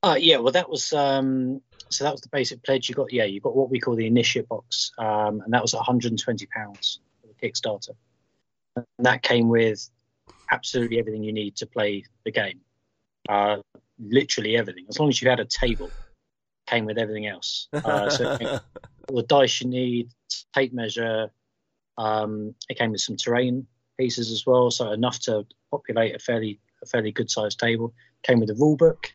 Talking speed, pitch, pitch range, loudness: 195 wpm, 120 Hz, 110-125 Hz, -24 LUFS